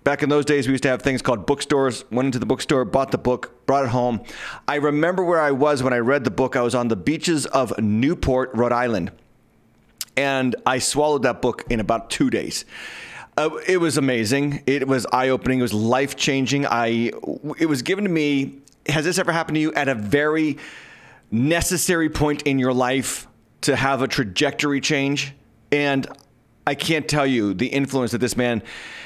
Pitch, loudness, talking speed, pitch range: 135 Hz, -21 LUFS, 195 wpm, 125-145 Hz